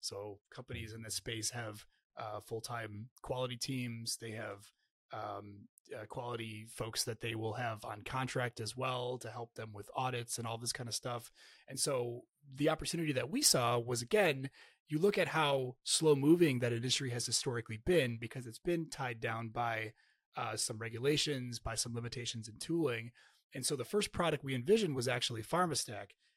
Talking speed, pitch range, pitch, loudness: 180 wpm, 115-140 Hz, 120 Hz, -36 LUFS